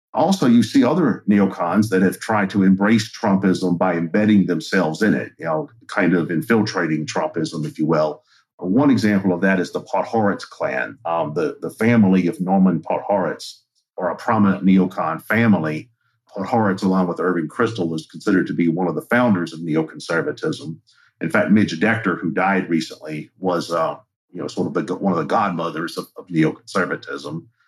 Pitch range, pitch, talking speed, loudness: 85-105 Hz, 95 Hz, 175 wpm, -19 LUFS